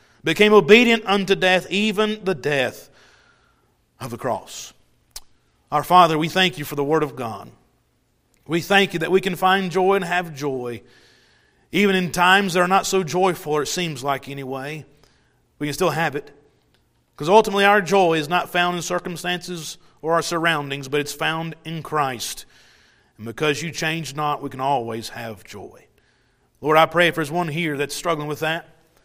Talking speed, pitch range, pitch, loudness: 180 wpm, 145-185 Hz, 165 Hz, -20 LUFS